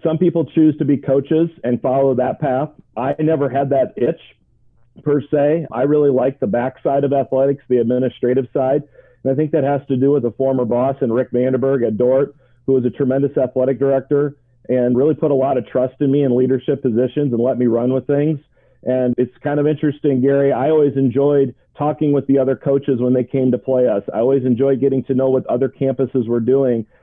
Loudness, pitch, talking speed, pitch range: -17 LUFS, 135 Hz, 220 wpm, 130-145 Hz